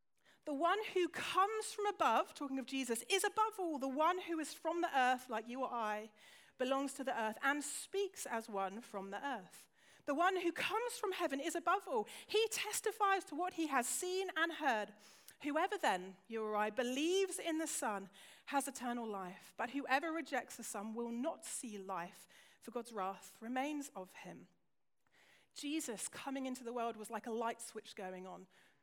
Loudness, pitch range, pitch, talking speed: -39 LUFS, 220-335 Hz, 270 Hz, 190 wpm